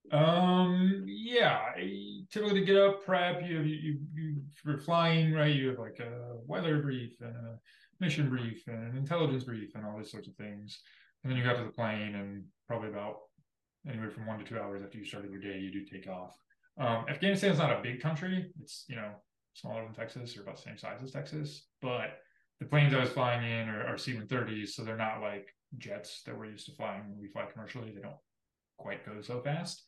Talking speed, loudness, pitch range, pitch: 225 wpm, -33 LUFS, 105-150 Hz, 125 Hz